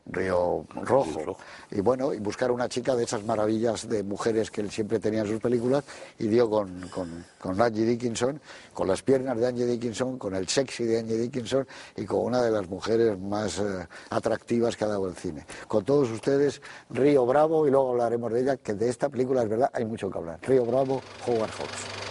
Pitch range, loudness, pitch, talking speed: 105-130 Hz, -27 LUFS, 120 Hz, 210 wpm